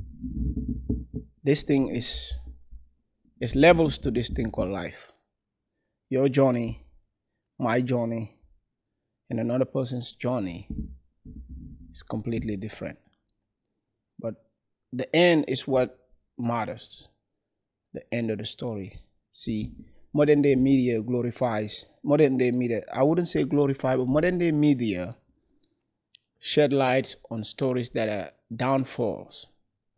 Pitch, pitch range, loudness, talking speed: 120 Hz, 105-135 Hz, -26 LUFS, 110 wpm